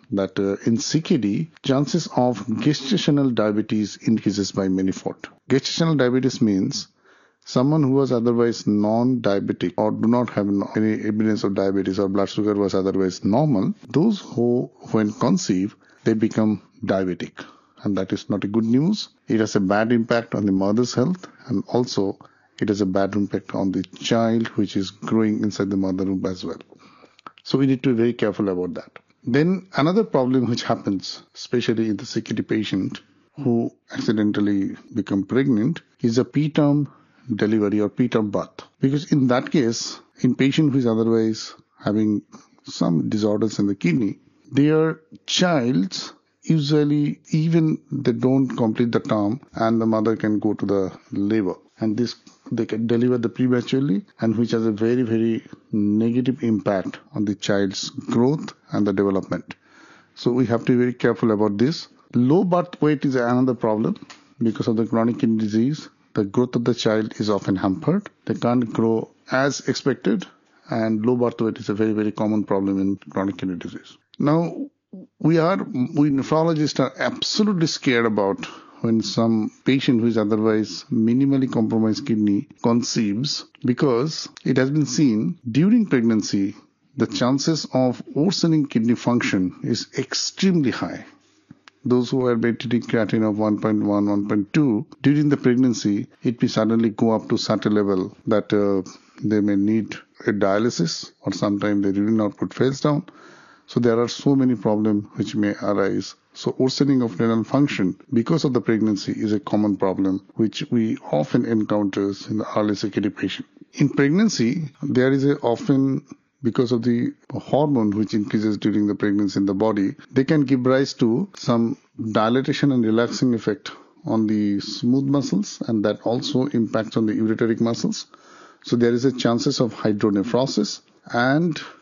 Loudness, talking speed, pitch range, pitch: -21 LUFS, 165 wpm, 105-130 Hz, 115 Hz